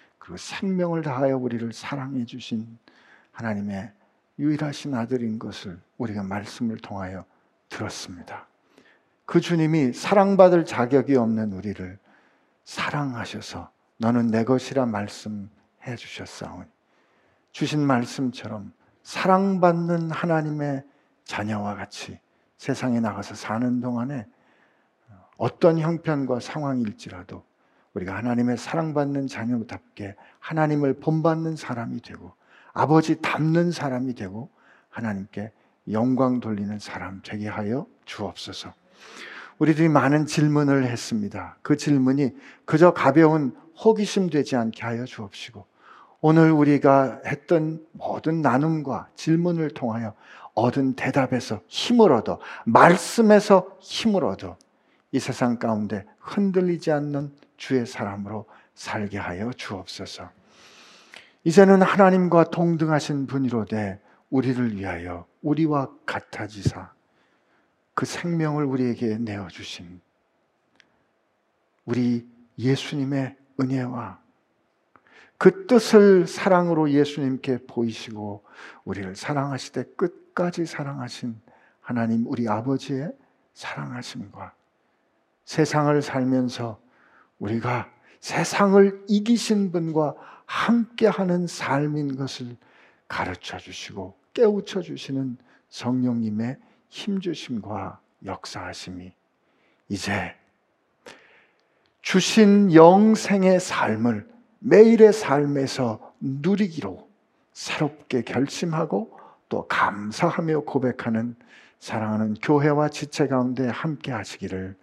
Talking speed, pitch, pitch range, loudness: 245 characters per minute, 135 Hz, 115-160 Hz, -23 LUFS